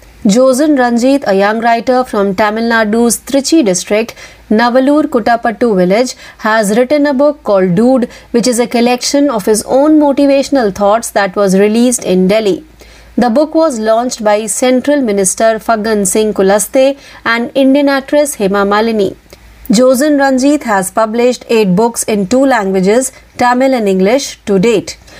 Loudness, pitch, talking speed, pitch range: -10 LUFS, 235 Hz, 150 wpm, 210-265 Hz